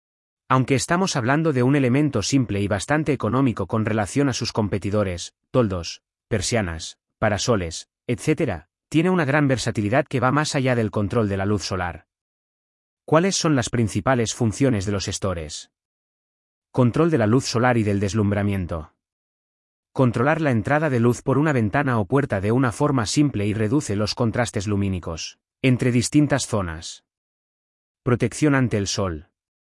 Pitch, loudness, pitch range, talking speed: 115 Hz, -22 LUFS, 100-135 Hz, 150 wpm